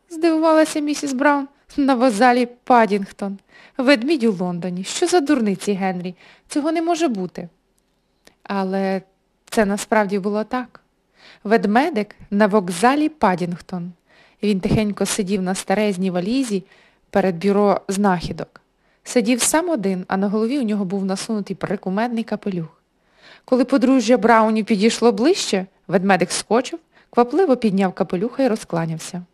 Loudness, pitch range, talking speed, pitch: -19 LUFS, 190-255 Hz, 120 wpm, 210 Hz